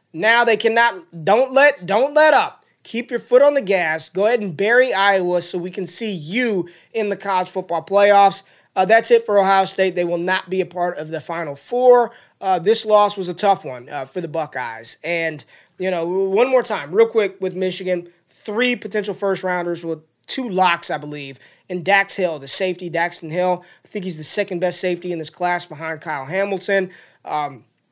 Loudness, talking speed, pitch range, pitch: -19 LUFS, 205 wpm, 175-210 Hz, 185 Hz